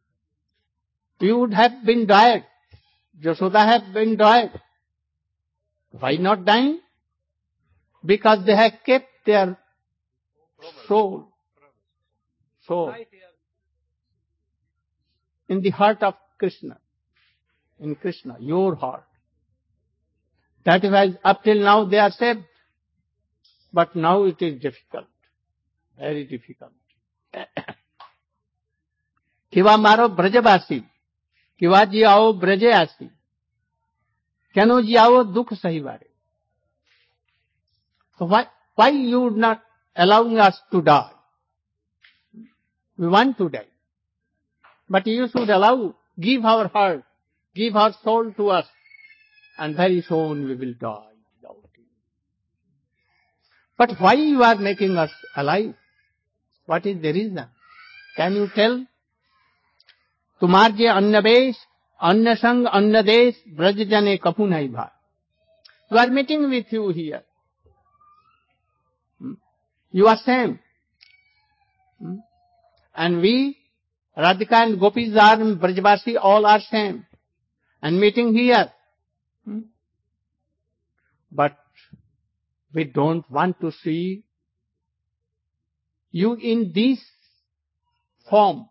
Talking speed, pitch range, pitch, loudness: 95 wpm, 145-225 Hz, 195 Hz, -18 LUFS